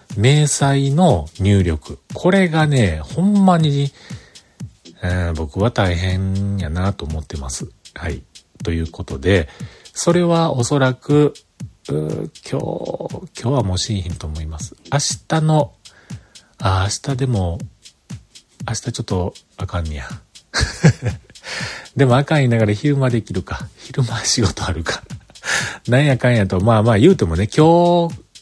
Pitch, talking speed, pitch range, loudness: 115 Hz, 245 characters per minute, 95-140 Hz, -18 LUFS